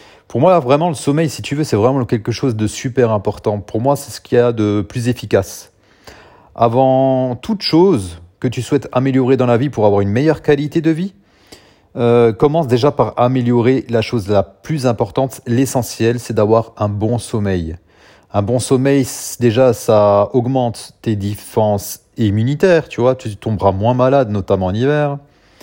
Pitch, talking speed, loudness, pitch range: 120 Hz, 180 wpm, -15 LUFS, 105-135 Hz